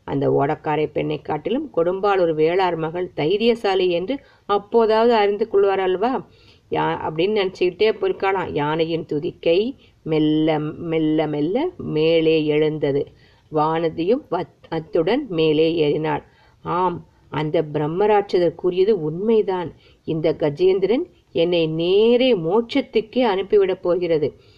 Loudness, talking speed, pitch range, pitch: -20 LUFS, 95 wpm, 155-220 Hz, 175 Hz